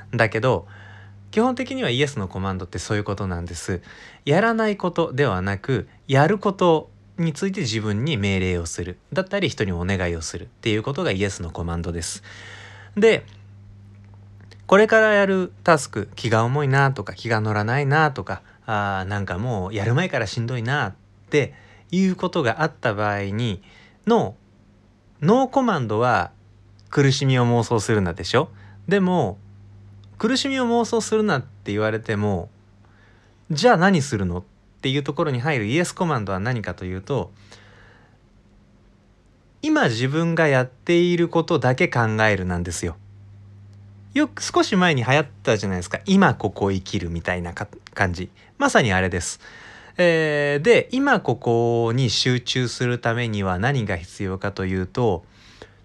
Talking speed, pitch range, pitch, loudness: 315 characters per minute, 100-150 Hz, 110 Hz, -22 LUFS